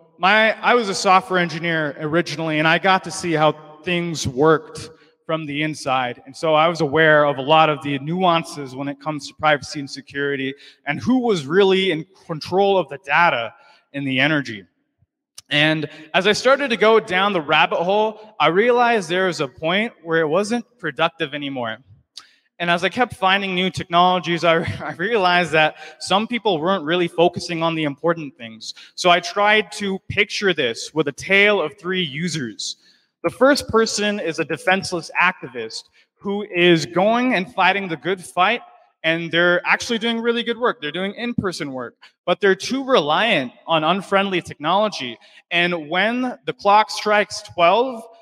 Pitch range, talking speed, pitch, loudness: 155-200 Hz, 175 wpm, 175 Hz, -19 LUFS